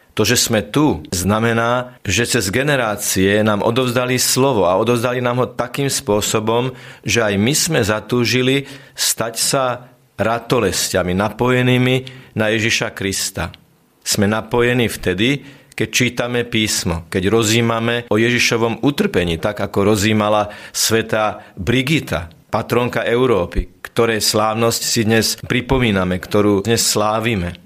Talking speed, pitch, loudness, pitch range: 120 wpm, 115 Hz, -17 LUFS, 105-125 Hz